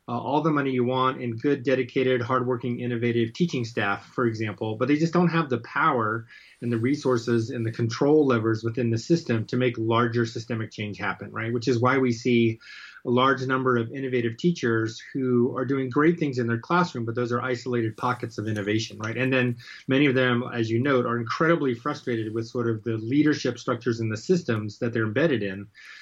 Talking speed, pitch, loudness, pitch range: 210 wpm, 120 Hz, -25 LUFS, 115-130 Hz